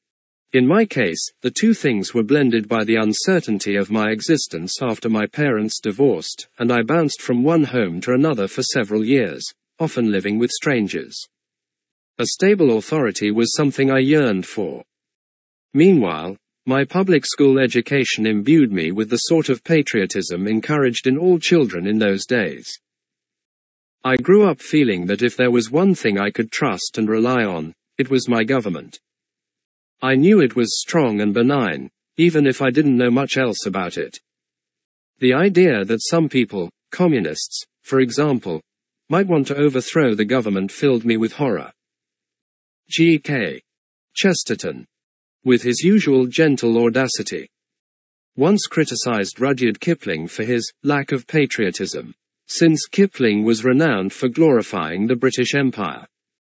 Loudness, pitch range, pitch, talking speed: -18 LUFS, 110-150 Hz, 130 Hz, 150 wpm